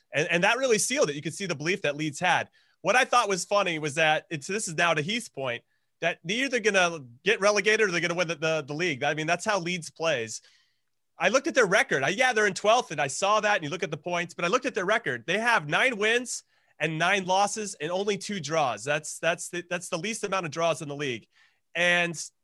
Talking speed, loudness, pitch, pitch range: 260 wpm, -26 LUFS, 180 Hz, 160-210 Hz